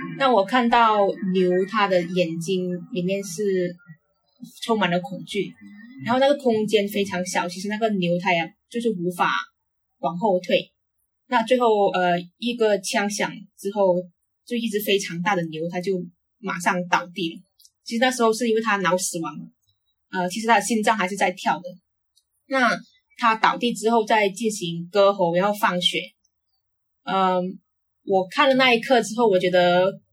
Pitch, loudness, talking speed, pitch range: 195 Hz, -22 LUFS, 235 characters per minute, 180-225 Hz